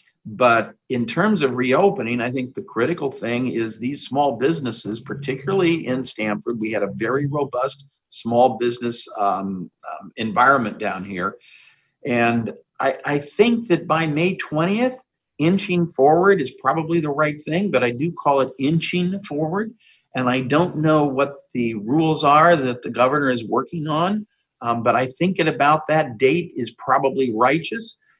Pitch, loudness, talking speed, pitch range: 140 Hz, -20 LUFS, 160 wpm, 125-170 Hz